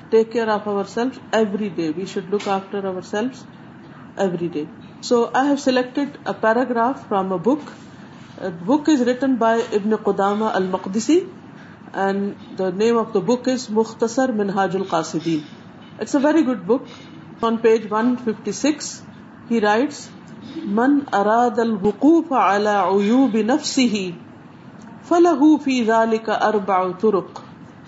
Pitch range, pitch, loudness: 200-250 Hz, 225 Hz, -20 LUFS